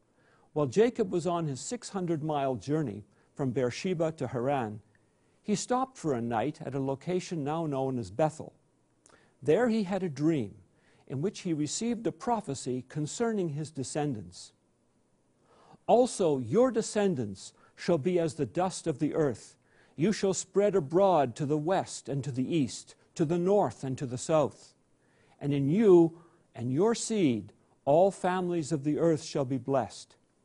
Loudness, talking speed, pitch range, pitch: -30 LUFS, 160 wpm, 135-190 Hz, 155 Hz